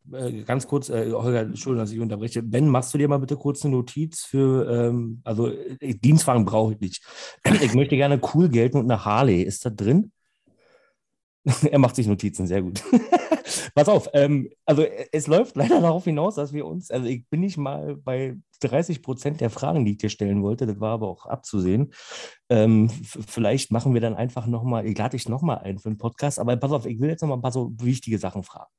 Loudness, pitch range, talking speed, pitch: -23 LUFS, 115-145 Hz, 200 wpm, 125 Hz